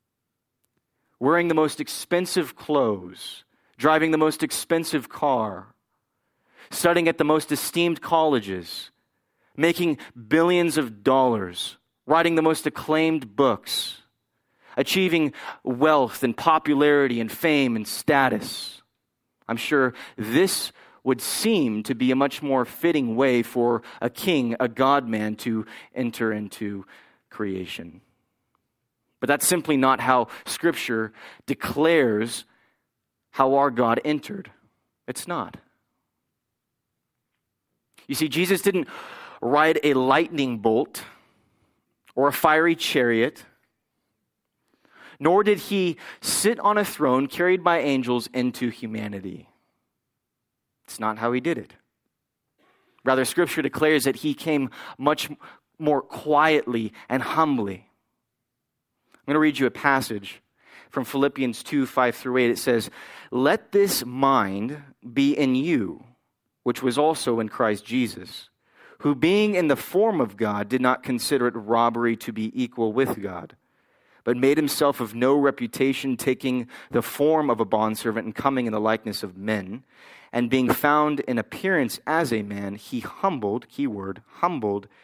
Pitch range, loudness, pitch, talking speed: 115-150 Hz, -23 LUFS, 130 Hz, 130 wpm